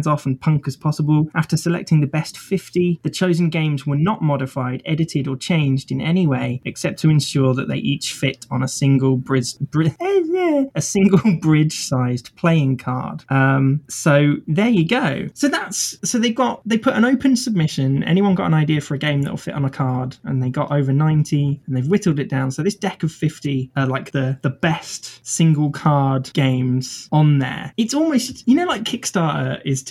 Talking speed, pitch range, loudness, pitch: 200 wpm, 135-175 Hz, -19 LUFS, 150 Hz